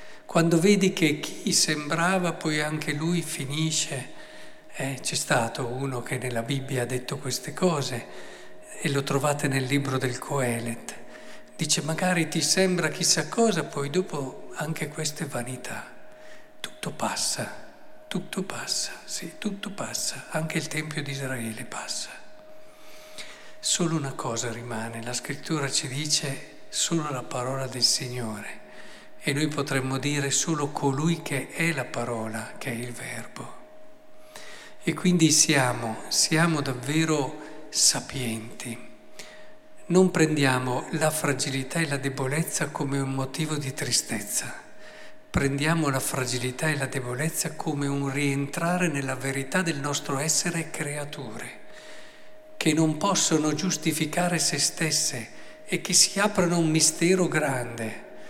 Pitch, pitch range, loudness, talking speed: 150 Hz, 135-170 Hz, -26 LUFS, 130 wpm